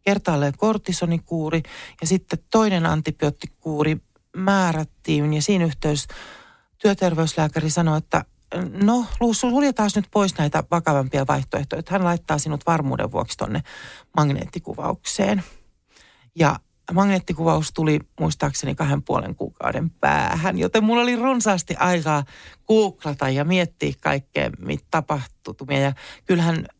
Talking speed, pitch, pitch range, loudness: 105 wpm, 165 Hz, 150-195 Hz, -22 LUFS